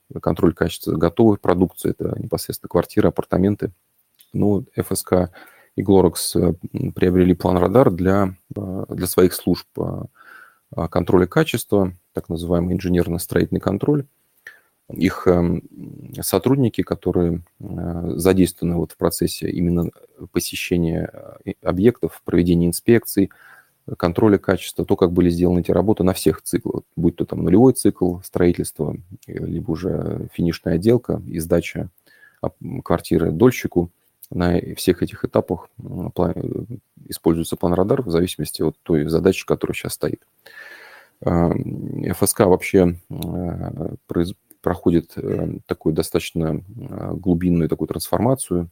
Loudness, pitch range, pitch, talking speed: -20 LUFS, 85-100 Hz, 90 Hz, 105 wpm